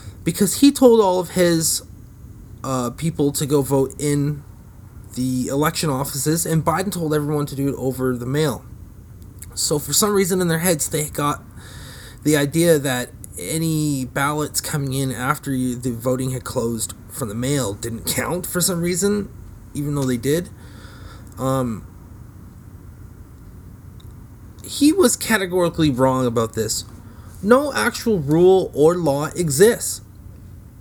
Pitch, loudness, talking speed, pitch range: 130 Hz, -20 LUFS, 140 wpm, 105-155 Hz